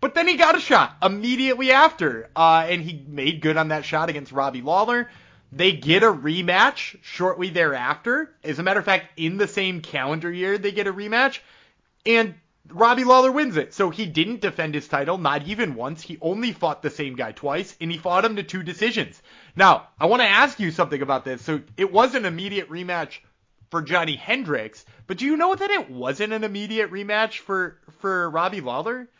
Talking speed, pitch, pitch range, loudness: 205 wpm, 185 Hz, 160-220 Hz, -21 LUFS